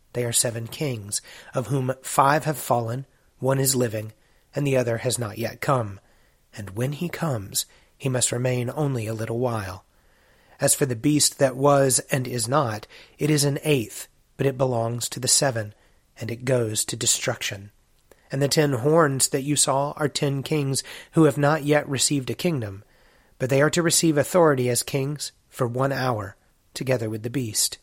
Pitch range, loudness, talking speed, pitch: 115-145 Hz, -23 LUFS, 185 wpm, 130 Hz